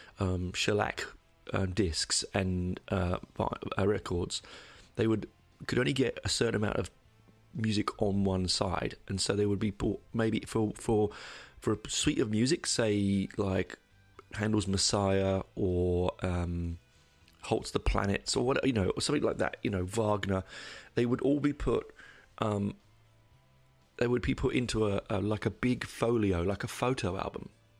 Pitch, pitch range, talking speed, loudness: 105 Hz, 95-110 Hz, 160 wpm, -31 LUFS